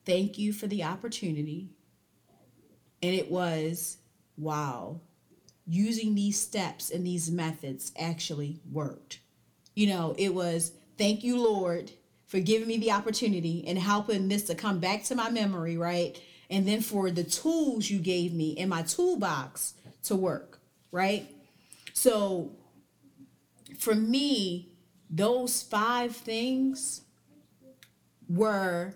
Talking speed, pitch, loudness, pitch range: 125 wpm, 190 Hz, -30 LUFS, 170-220 Hz